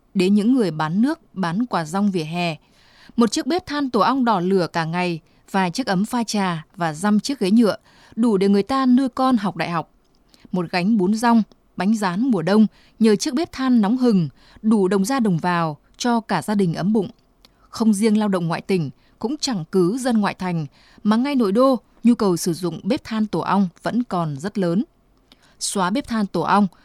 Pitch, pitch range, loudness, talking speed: 205 Hz, 180-235 Hz, -20 LUFS, 215 wpm